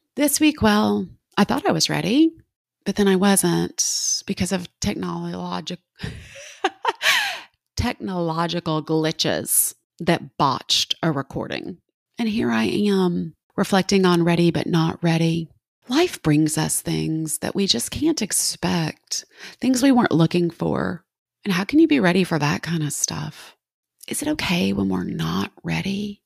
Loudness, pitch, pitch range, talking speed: -21 LUFS, 175 Hz, 160-205 Hz, 145 wpm